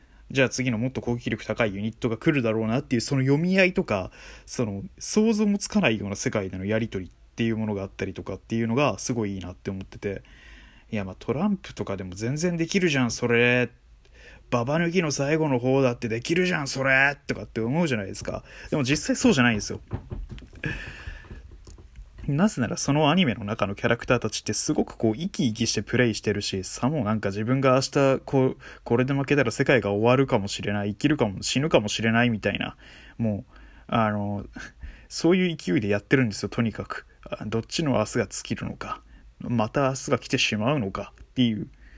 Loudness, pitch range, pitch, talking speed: -25 LUFS, 105-140 Hz, 120 Hz, 425 characters per minute